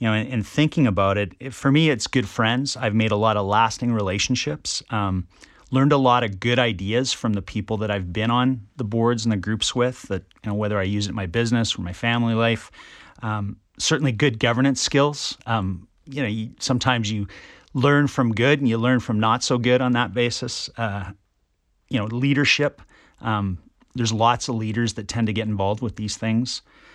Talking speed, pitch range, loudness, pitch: 210 wpm, 105-125 Hz, -22 LUFS, 115 Hz